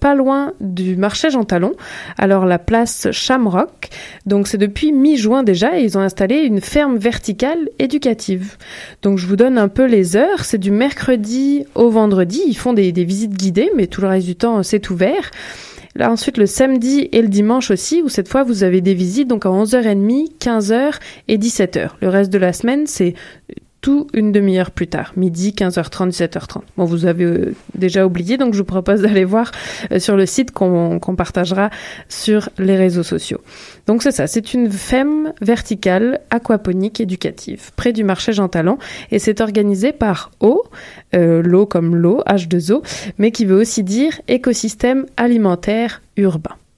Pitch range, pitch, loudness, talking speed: 190-245 Hz, 210 Hz, -15 LUFS, 180 wpm